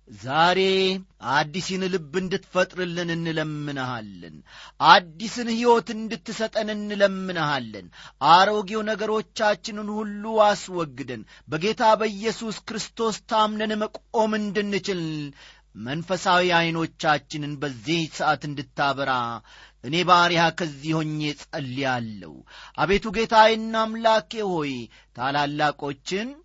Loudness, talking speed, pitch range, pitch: -23 LUFS, 75 wpm, 150-215 Hz, 180 Hz